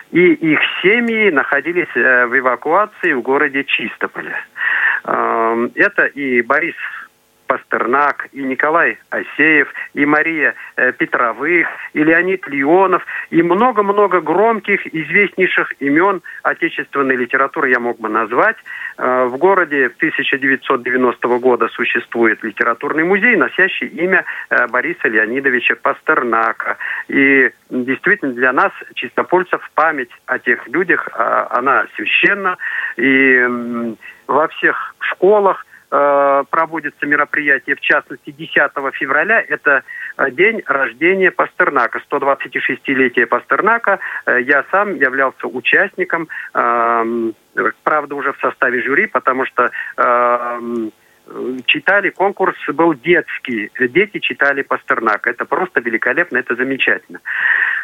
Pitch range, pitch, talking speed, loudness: 125-175 Hz, 140 Hz, 100 wpm, -15 LUFS